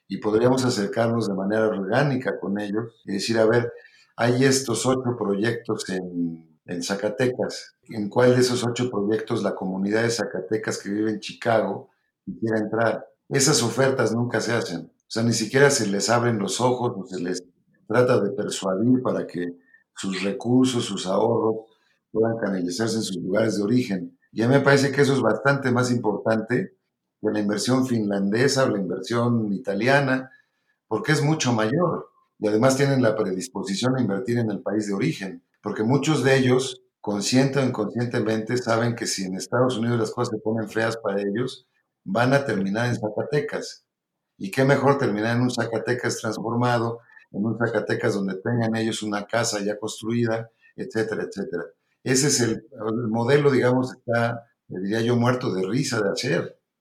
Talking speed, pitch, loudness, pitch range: 170 wpm, 115 Hz, -23 LUFS, 105-125 Hz